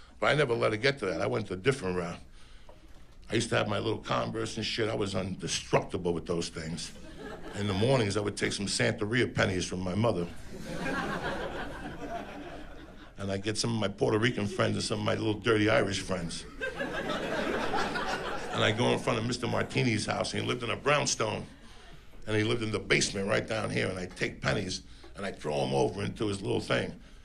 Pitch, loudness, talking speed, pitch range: 105 Hz, -31 LUFS, 210 wpm, 95-115 Hz